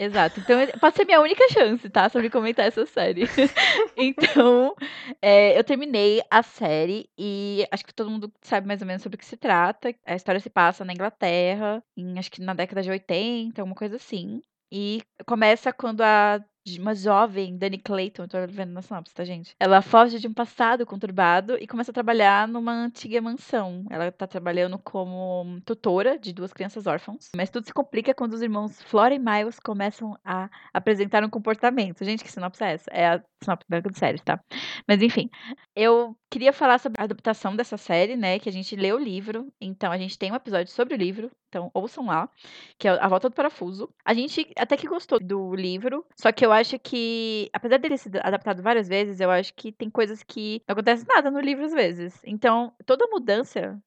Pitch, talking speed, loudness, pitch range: 215 Hz, 200 wpm, -23 LUFS, 190-240 Hz